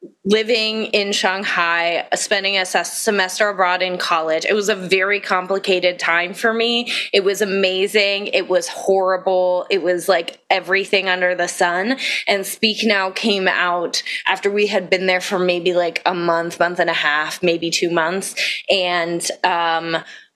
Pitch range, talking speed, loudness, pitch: 175-200 Hz, 160 wpm, -18 LUFS, 185 Hz